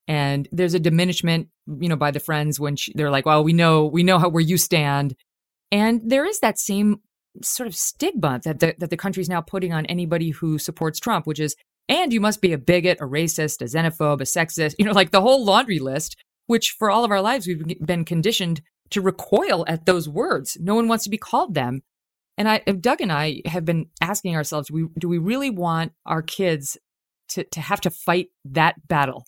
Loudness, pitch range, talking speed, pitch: -21 LUFS, 155-195 Hz, 225 wpm, 170 Hz